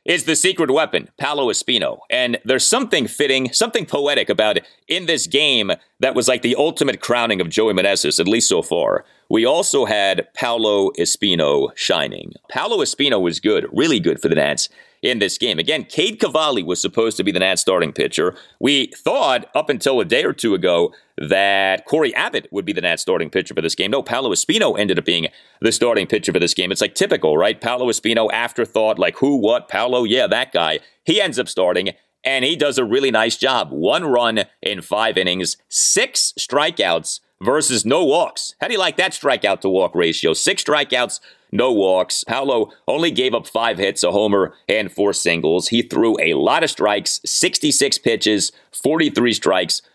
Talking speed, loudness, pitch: 195 wpm, -17 LUFS, 155 Hz